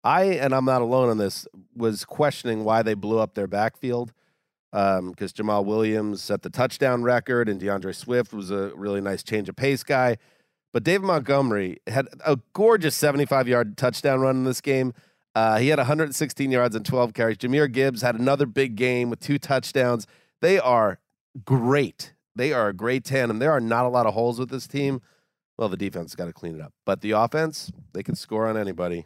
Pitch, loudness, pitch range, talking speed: 120 Hz, -24 LUFS, 105-135 Hz, 205 wpm